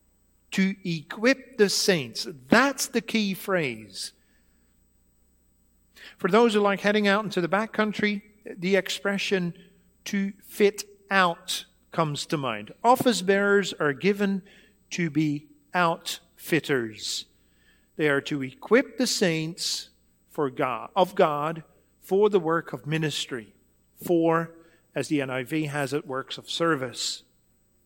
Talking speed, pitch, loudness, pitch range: 125 wpm, 170 Hz, -26 LUFS, 135-200 Hz